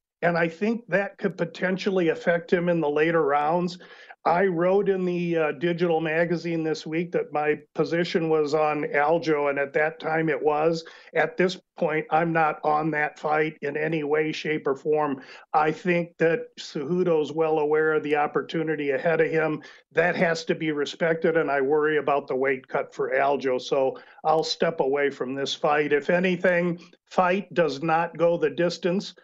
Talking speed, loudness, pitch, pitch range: 180 wpm, -24 LUFS, 160 Hz, 150-175 Hz